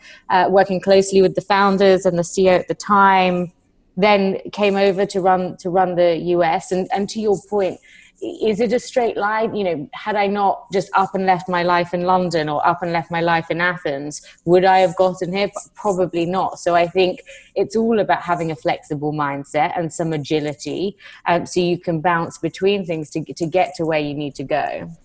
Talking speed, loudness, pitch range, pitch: 215 wpm, -19 LUFS, 170-195 Hz, 180 Hz